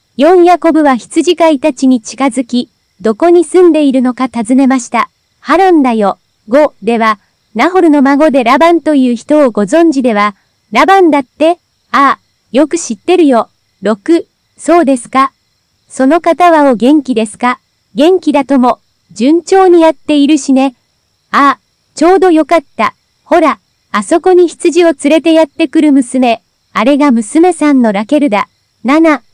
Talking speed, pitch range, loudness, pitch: 280 characters per minute, 250-330 Hz, -9 LUFS, 290 Hz